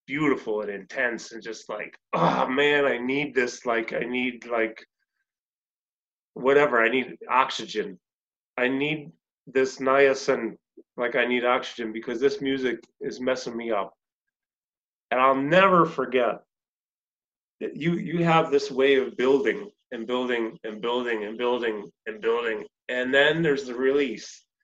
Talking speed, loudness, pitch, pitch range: 150 wpm, -24 LUFS, 130 Hz, 120-145 Hz